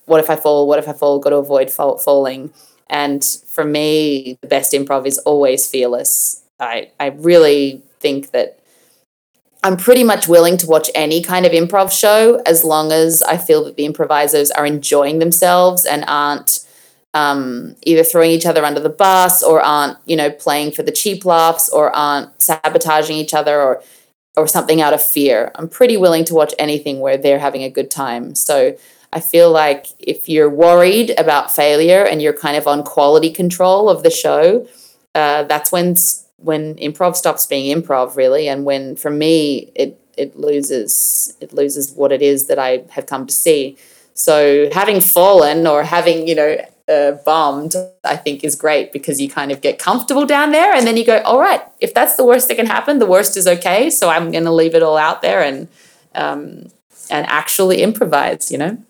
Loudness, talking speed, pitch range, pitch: -13 LUFS, 195 wpm, 145-180 Hz, 155 Hz